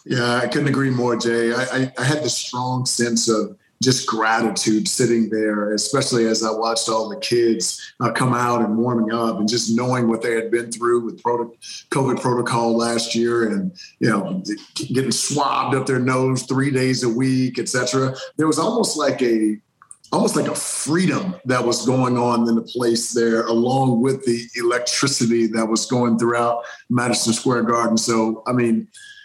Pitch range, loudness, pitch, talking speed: 115-130 Hz, -20 LUFS, 120 Hz, 180 wpm